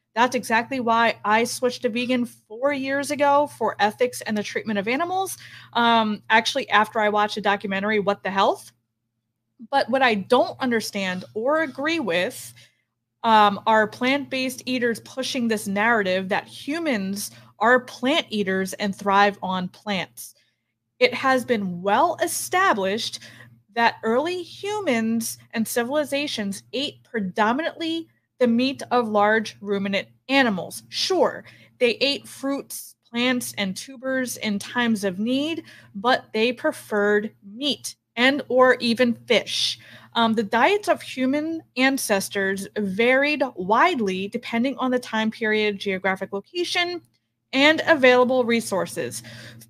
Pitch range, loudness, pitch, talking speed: 205-265 Hz, -22 LUFS, 230 Hz, 130 wpm